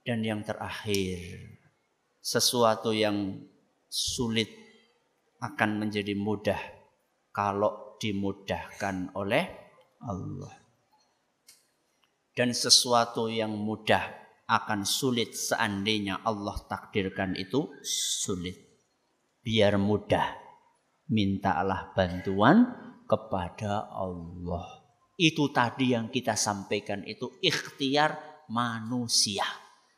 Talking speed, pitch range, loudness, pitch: 75 wpm, 100-120 Hz, -28 LUFS, 105 Hz